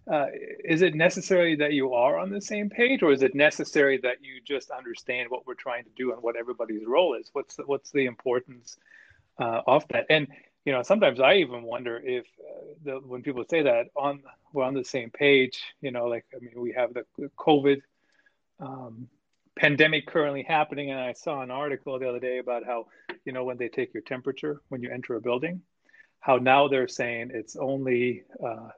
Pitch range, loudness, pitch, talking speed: 125-150 Hz, -26 LUFS, 135 Hz, 215 wpm